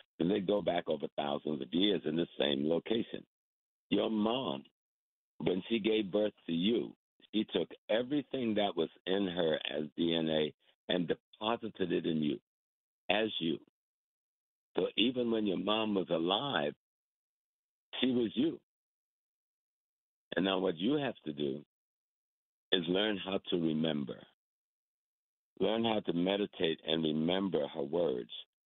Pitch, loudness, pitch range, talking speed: 100 Hz, -34 LUFS, 80-110 Hz, 140 wpm